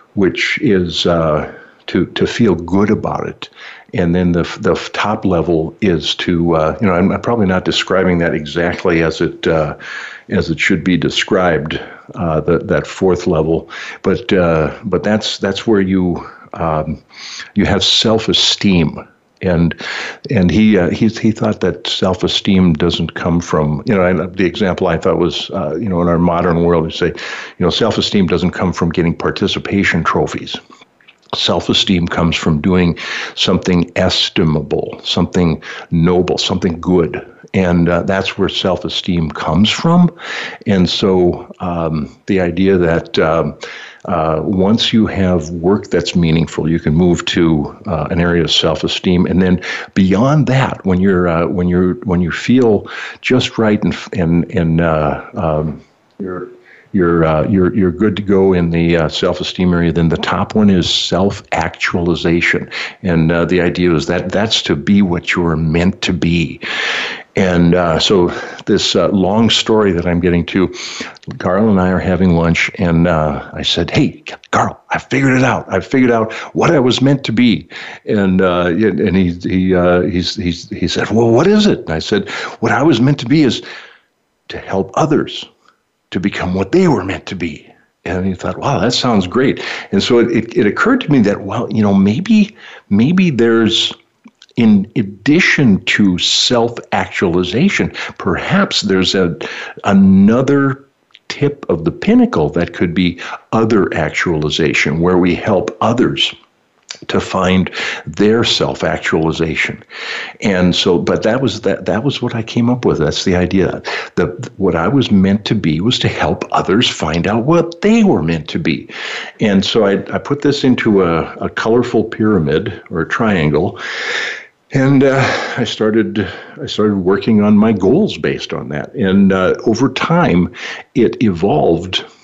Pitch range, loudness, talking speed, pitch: 85-110 Hz, -14 LUFS, 170 wpm, 90 Hz